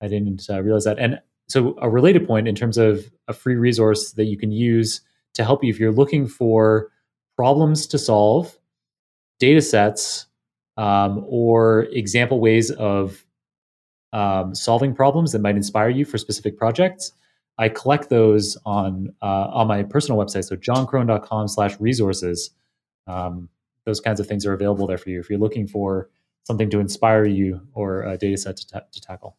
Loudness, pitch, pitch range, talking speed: -20 LUFS, 110 Hz, 100-115 Hz, 175 wpm